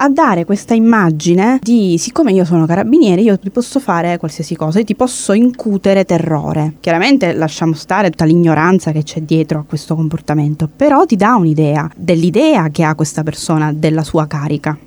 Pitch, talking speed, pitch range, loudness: 170 Hz, 175 wpm, 160-215 Hz, -13 LUFS